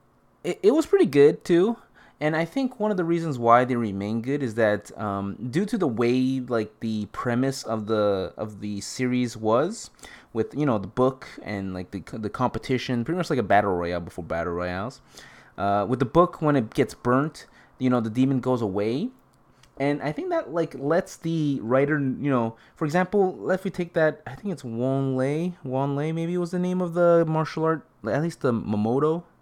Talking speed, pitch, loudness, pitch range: 205 wpm, 130 Hz, -25 LUFS, 115-165 Hz